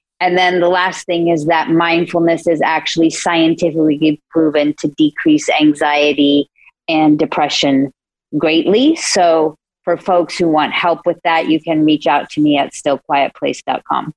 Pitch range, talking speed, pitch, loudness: 150-170 Hz, 145 wpm, 160 Hz, -14 LUFS